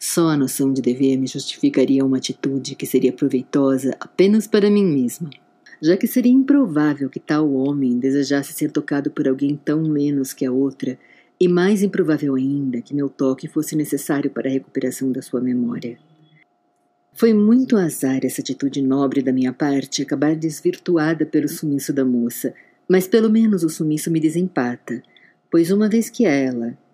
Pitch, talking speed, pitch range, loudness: 145 Hz, 165 wpm, 135-170 Hz, -19 LUFS